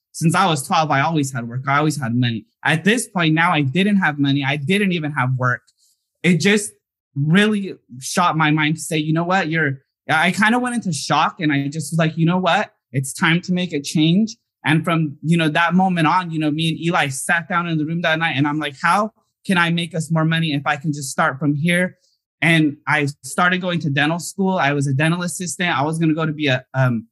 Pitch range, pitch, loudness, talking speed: 145-175 Hz, 160 Hz, -18 LUFS, 250 wpm